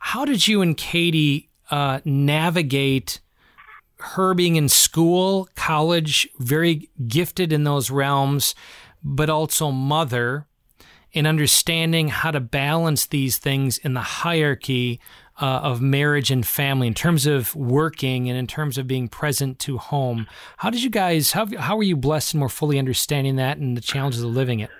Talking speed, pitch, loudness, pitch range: 160 wpm, 145 Hz, -20 LUFS, 130-160 Hz